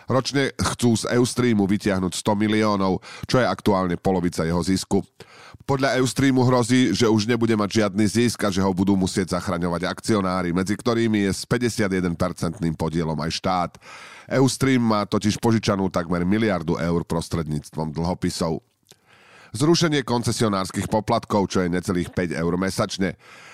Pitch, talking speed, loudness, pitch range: 100 Hz, 140 wpm, -22 LUFS, 90-115 Hz